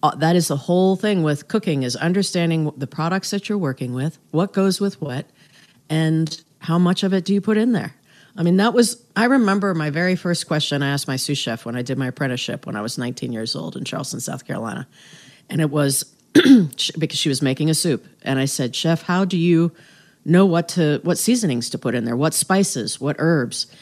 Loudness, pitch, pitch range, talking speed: -20 LUFS, 160 Hz, 140-185 Hz, 225 wpm